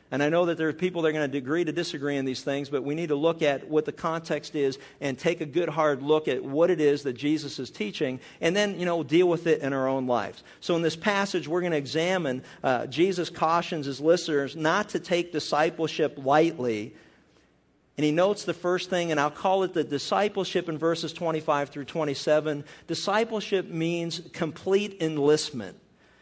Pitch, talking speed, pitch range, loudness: 160 Hz, 210 wpm, 145-175 Hz, -27 LUFS